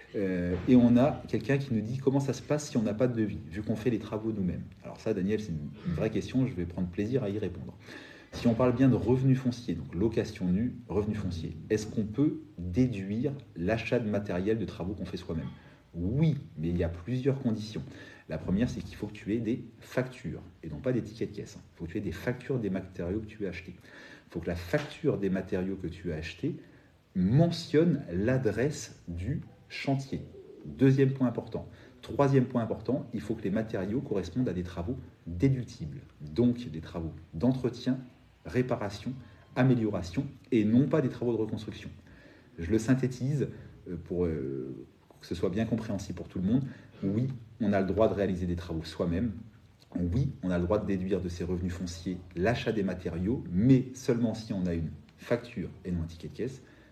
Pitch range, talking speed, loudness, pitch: 90-125 Hz, 205 wpm, -31 LUFS, 110 Hz